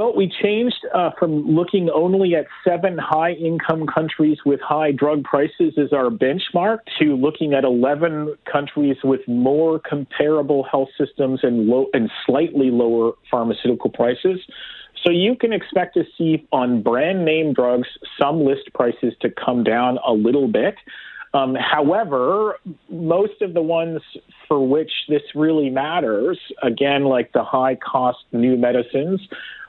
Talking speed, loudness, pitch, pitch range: 150 wpm, -19 LUFS, 150 Hz, 135-170 Hz